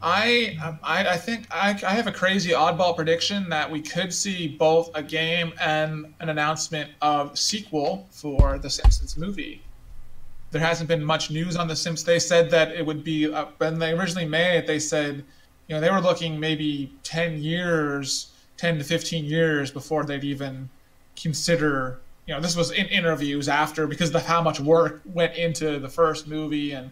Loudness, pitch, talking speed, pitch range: -24 LUFS, 160 Hz, 185 wpm, 150-170 Hz